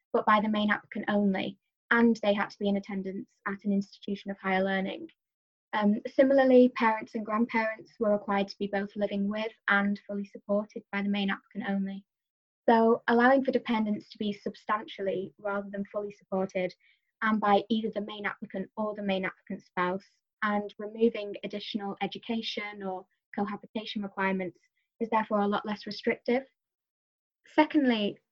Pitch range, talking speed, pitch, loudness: 200-225 Hz, 160 wpm, 205 Hz, -29 LUFS